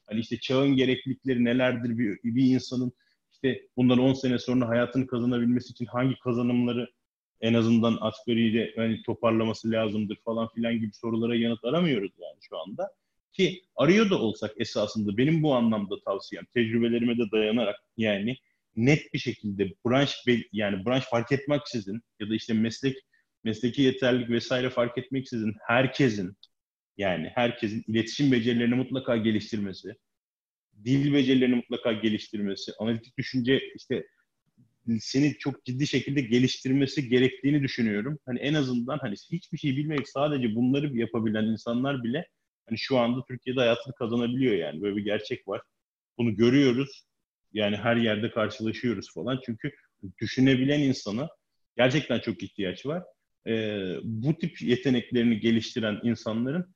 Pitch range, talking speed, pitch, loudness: 115-130 Hz, 135 wpm, 120 Hz, -27 LUFS